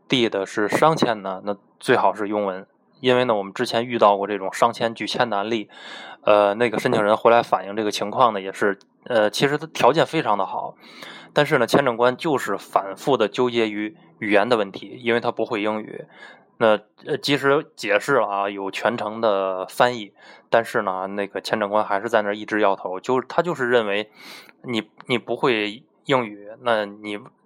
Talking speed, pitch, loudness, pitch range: 285 characters per minute, 105 Hz, -21 LUFS, 100-120 Hz